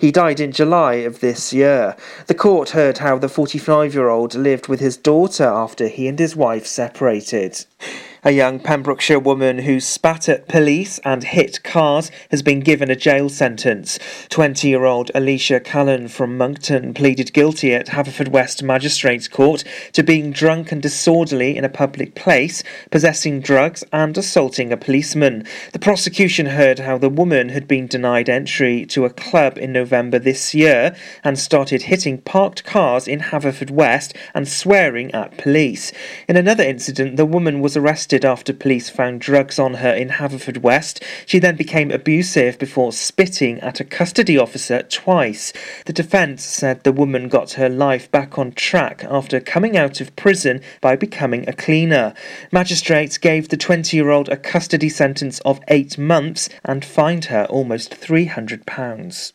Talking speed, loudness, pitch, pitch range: 165 wpm, -16 LUFS, 140 Hz, 130-155 Hz